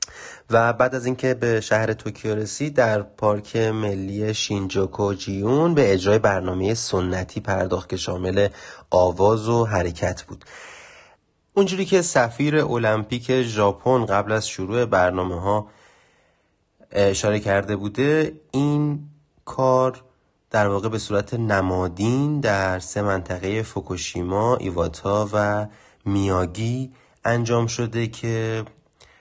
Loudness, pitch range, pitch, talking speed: -22 LUFS, 100-125 Hz, 105 Hz, 110 wpm